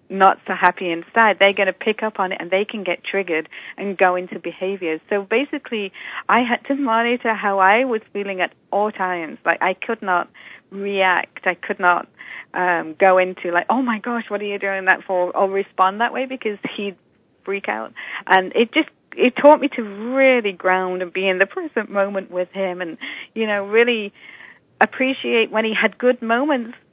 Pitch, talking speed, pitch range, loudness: 200 Hz, 200 wpm, 185-230 Hz, -19 LUFS